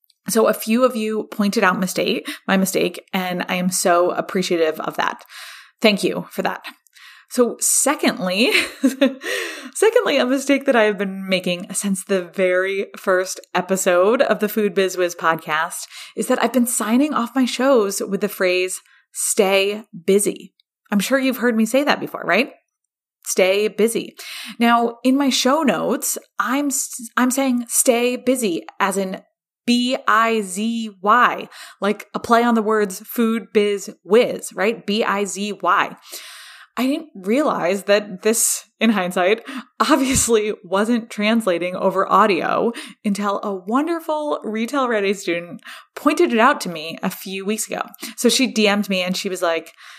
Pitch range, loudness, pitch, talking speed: 195-250 Hz, -19 LUFS, 215 Hz, 155 wpm